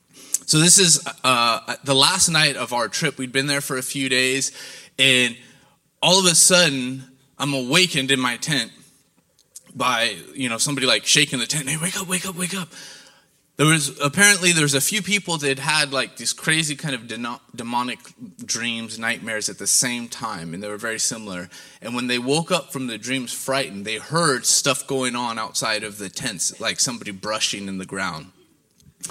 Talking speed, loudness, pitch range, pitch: 195 wpm, -19 LUFS, 120-160 Hz, 135 Hz